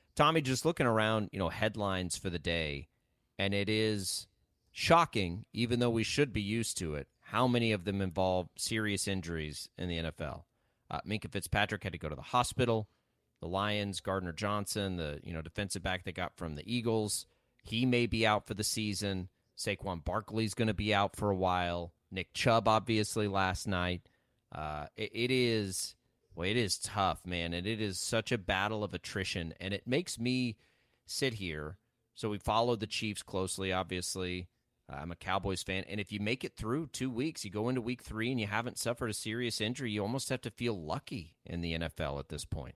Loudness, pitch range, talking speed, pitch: -34 LUFS, 90-115 Hz, 200 wpm, 100 Hz